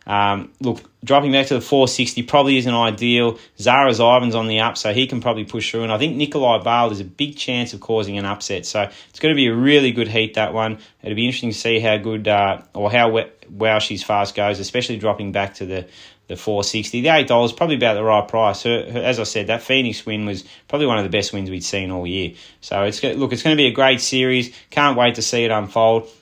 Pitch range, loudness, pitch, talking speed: 105-125 Hz, -18 LUFS, 115 Hz, 250 wpm